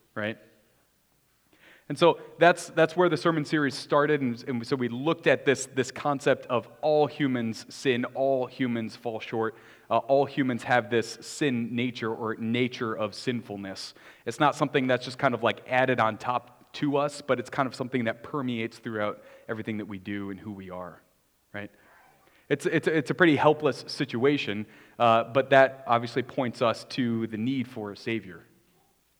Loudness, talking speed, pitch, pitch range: -27 LUFS, 180 wpm, 120 Hz, 110-140 Hz